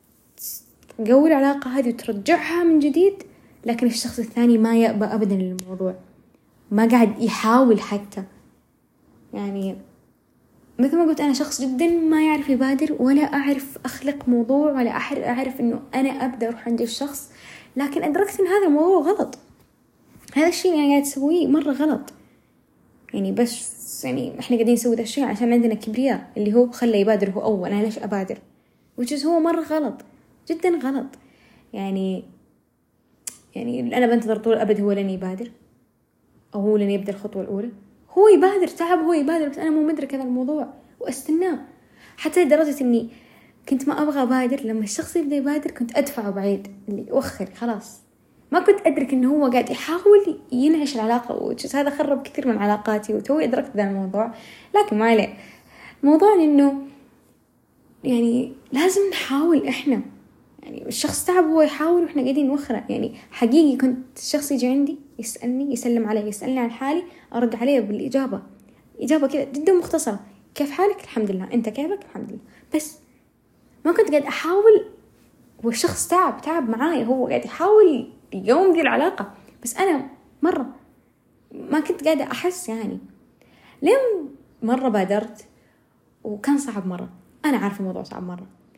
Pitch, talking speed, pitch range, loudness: 265 Hz, 150 wpm, 230-305 Hz, -21 LUFS